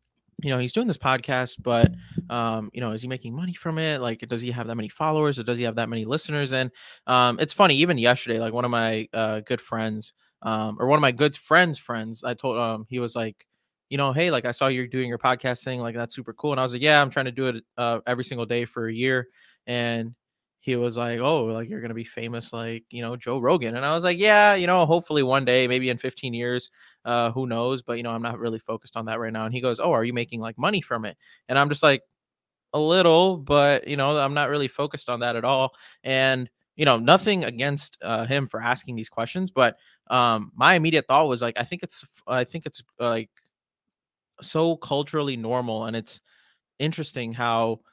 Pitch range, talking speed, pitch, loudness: 115-145 Hz, 240 wpm, 125 Hz, -24 LUFS